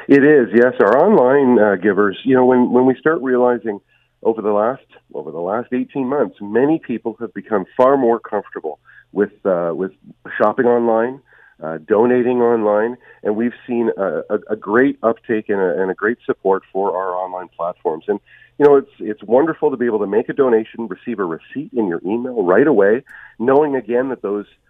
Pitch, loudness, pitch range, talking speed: 120 Hz, -17 LUFS, 105-125 Hz, 195 wpm